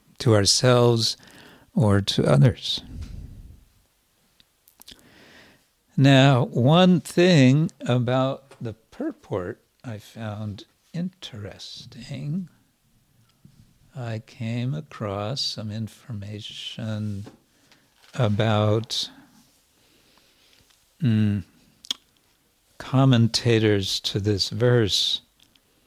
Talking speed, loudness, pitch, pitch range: 60 wpm, -22 LUFS, 115 Hz, 105-130 Hz